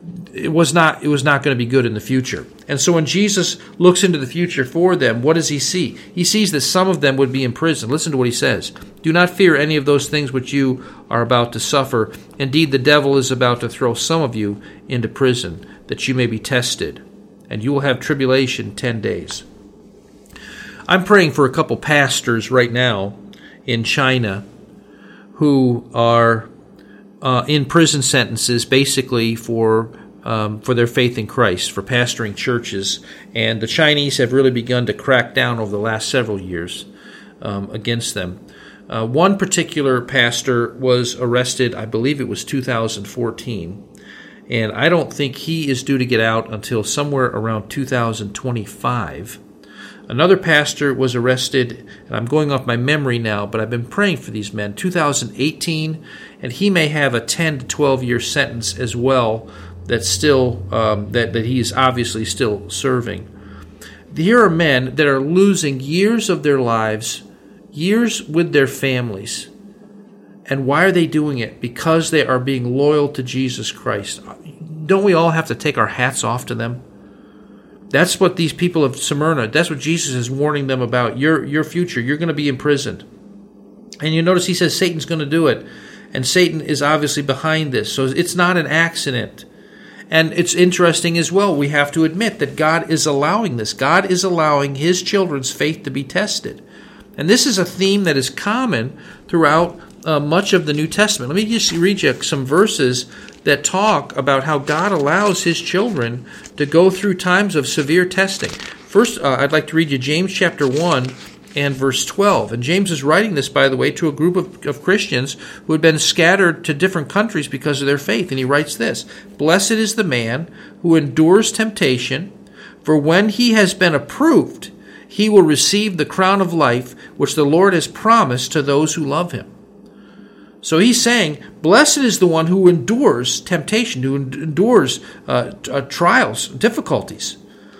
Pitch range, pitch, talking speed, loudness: 120-170 Hz, 145 Hz, 180 wpm, -16 LUFS